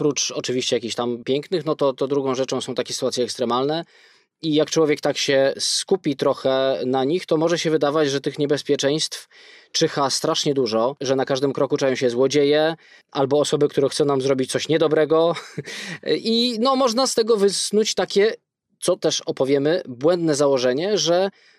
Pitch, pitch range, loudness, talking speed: 145 Hz, 135-165 Hz, -21 LUFS, 170 wpm